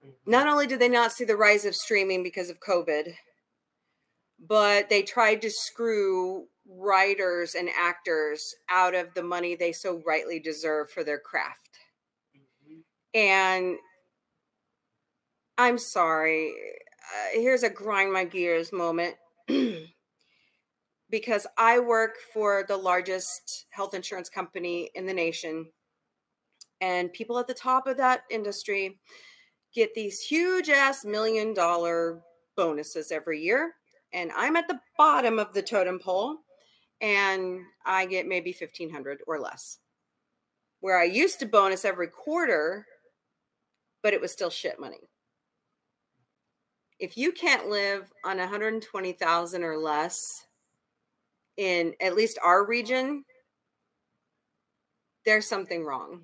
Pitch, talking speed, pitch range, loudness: 195 Hz, 125 wpm, 175-230 Hz, -26 LUFS